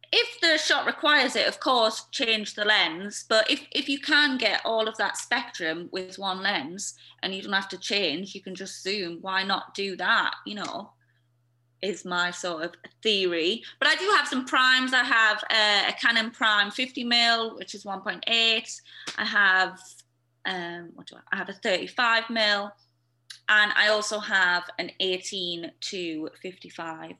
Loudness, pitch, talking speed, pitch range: -24 LUFS, 200 Hz, 175 wpm, 180-230 Hz